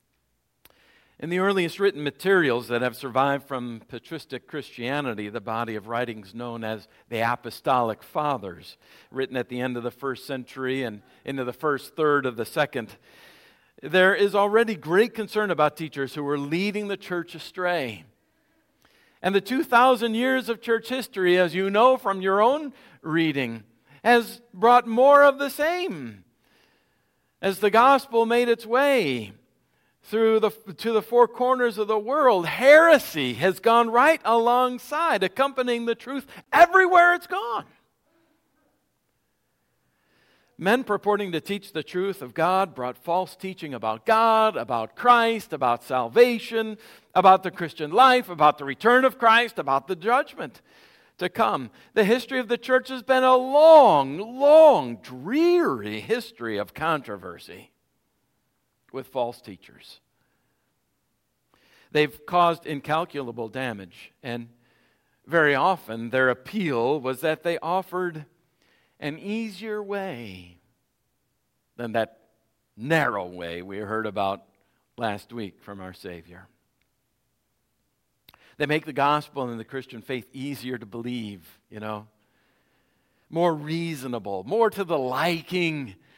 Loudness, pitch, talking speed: -23 LUFS, 165 Hz, 130 wpm